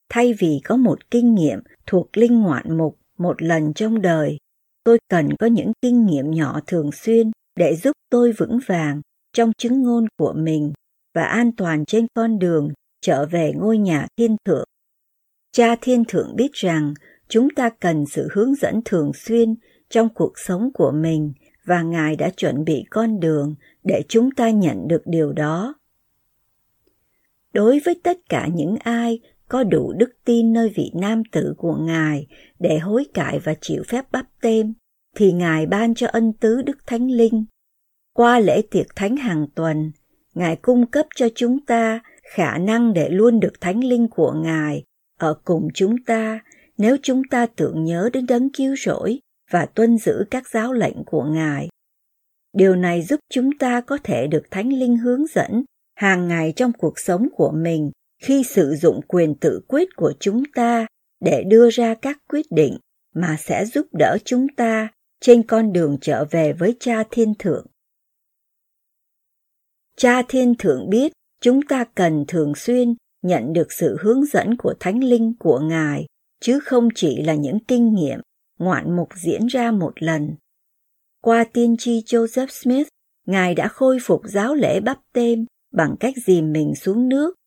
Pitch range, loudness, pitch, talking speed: 165-240 Hz, -19 LUFS, 225 Hz, 175 wpm